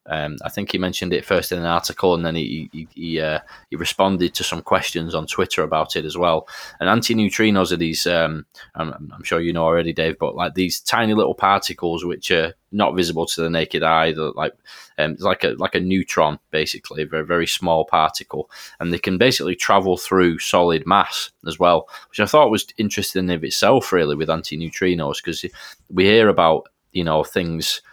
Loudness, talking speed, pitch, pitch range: -19 LUFS, 200 wpm, 85 Hz, 80-95 Hz